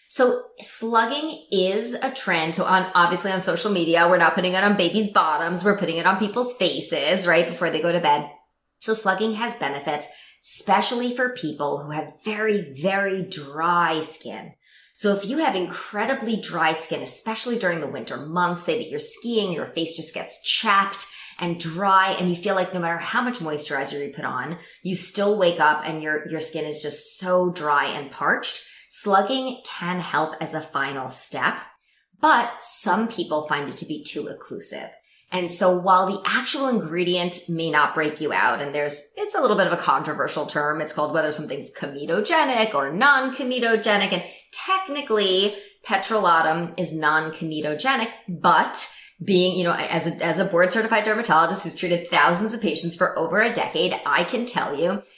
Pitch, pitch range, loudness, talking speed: 180 Hz, 160-215 Hz, -22 LUFS, 180 wpm